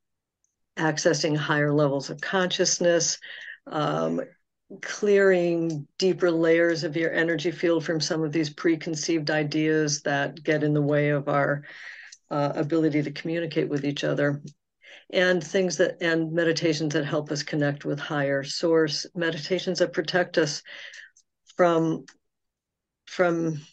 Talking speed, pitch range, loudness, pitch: 130 wpm, 150-175 Hz, -25 LUFS, 165 Hz